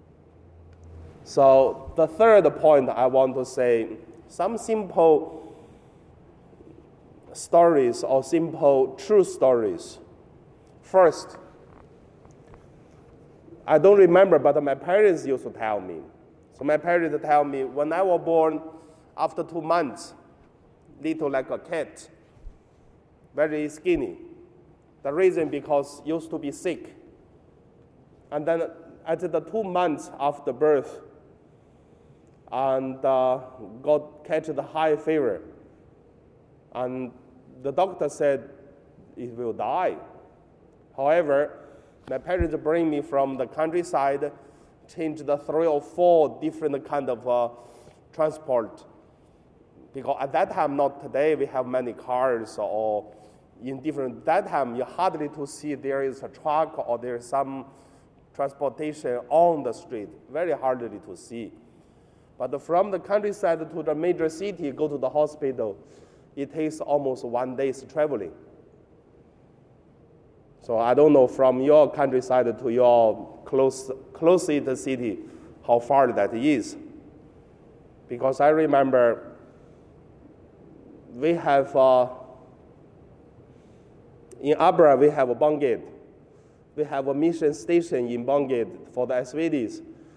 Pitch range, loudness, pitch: 130-165 Hz, -24 LUFS, 145 Hz